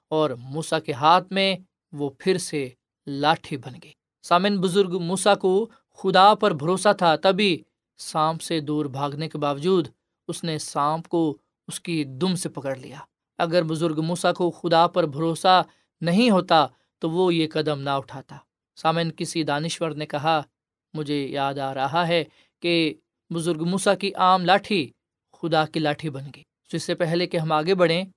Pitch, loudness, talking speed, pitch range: 165 Hz, -23 LUFS, 170 wpm, 150-180 Hz